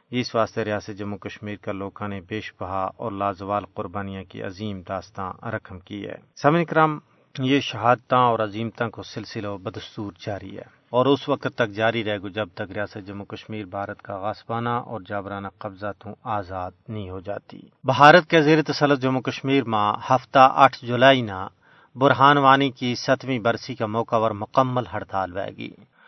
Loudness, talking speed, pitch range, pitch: -22 LUFS, 170 wpm, 100-130 Hz, 110 Hz